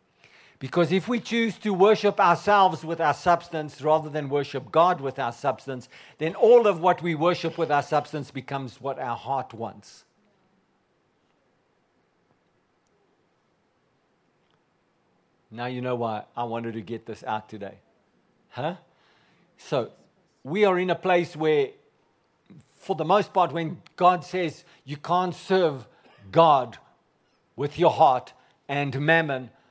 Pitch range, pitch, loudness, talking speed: 130-180 Hz, 155 Hz, -24 LUFS, 135 wpm